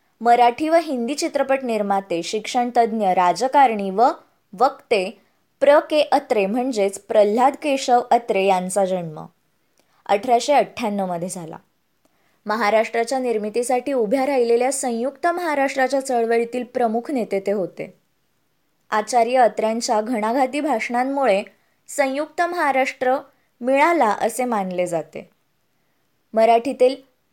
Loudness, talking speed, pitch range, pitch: -20 LUFS, 95 wpm, 210-270 Hz, 240 Hz